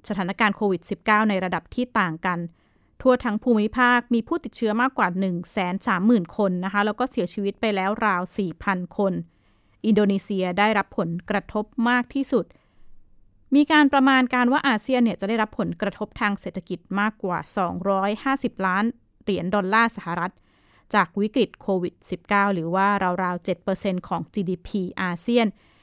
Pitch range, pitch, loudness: 185-230 Hz, 205 Hz, -23 LUFS